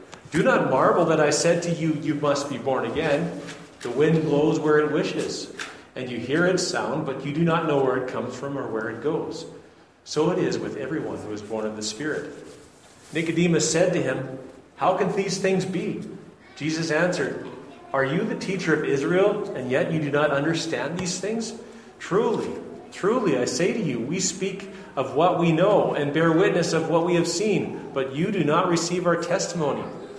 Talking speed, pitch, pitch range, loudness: 200 wpm, 160 Hz, 145-180 Hz, -24 LUFS